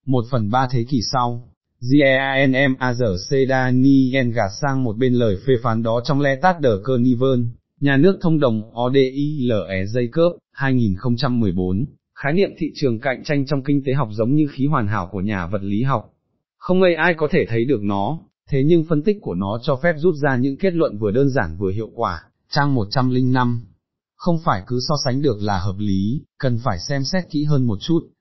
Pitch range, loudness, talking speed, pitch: 115-140 Hz, -19 LUFS, 225 wpm, 130 Hz